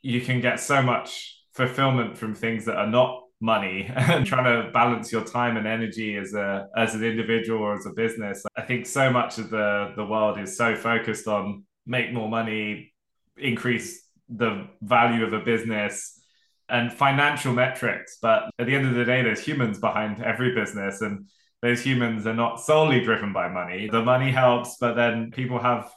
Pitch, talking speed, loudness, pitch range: 115 Hz, 185 wpm, -24 LUFS, 110-125 Hz